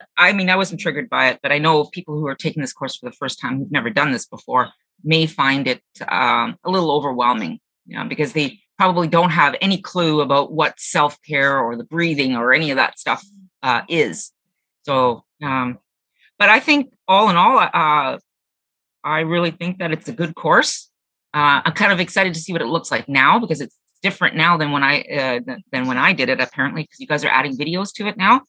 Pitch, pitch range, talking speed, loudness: 155 Hz, 140-180 Hz, 225 wpm, -18 LUFS